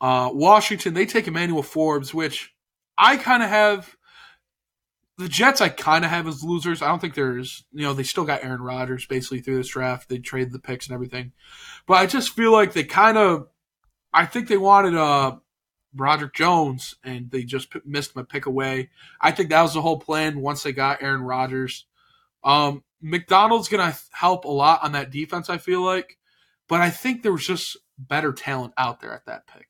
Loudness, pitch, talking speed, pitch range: -21 LUFS, 155 Hz, 200 wpm, 135-185 Hz